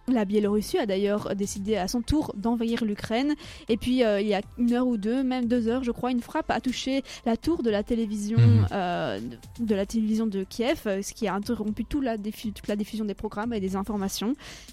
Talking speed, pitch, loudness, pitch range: 225 wpm, 220 Hz, -27 LUFS, 205-240 Hz